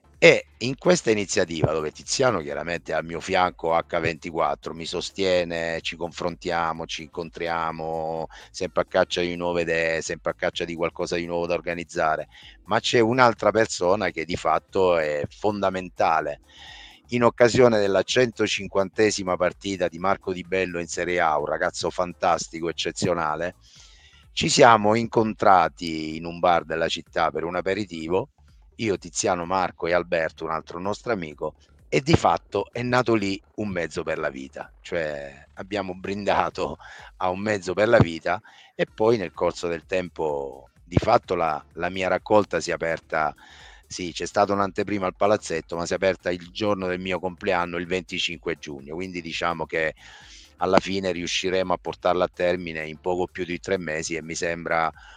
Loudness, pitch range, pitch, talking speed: -24 LUFS, 80-95 Hz, 90 Hz, 165 wpm